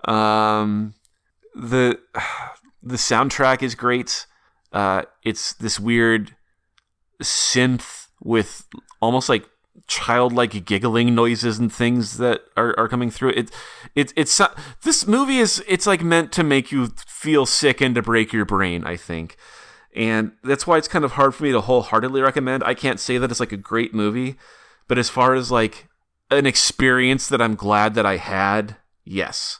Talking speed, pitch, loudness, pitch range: 160 wpm, 120 Hz, -19 LUFS, 110-135 Hz